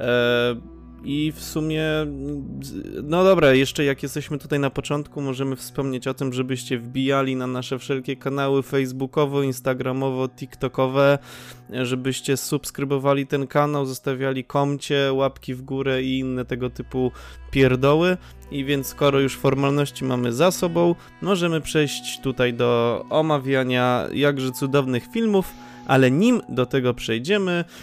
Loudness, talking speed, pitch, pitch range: -22 LUFS, 125 wpm, 135 Hz, 130-145 Hz